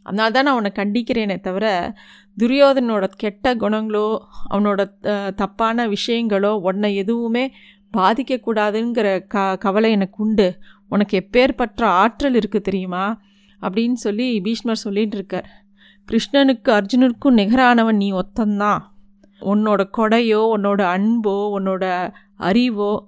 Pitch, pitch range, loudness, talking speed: 210 Hz, 200-230 Hz, -18 LUFS, 105 wpm